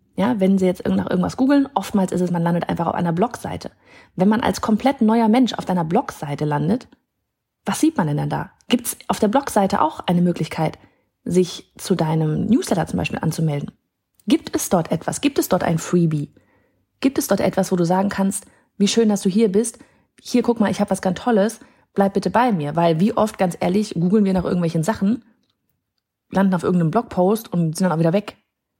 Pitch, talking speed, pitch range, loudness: 195 Hz, 210 wpm, 175-230 Hz, -20 LUFS